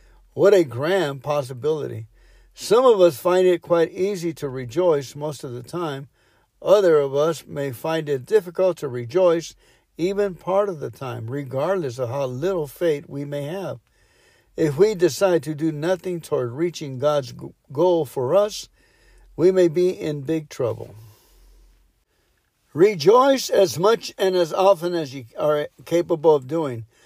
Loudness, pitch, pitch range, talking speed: -21 LUFS, 160 Hz, 140-185 Hz, 155 wpm